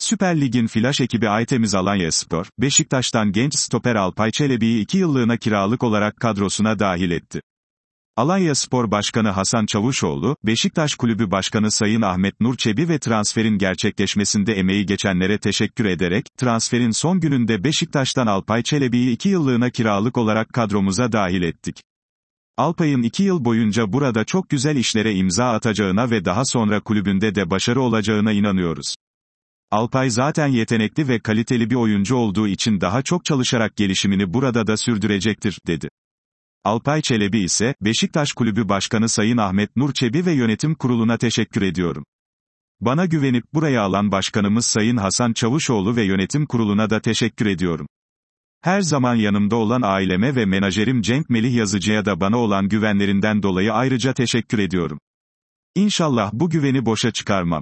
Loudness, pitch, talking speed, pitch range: -19 LUFS, 115 Hz, 145 wpm, 105-130 Hz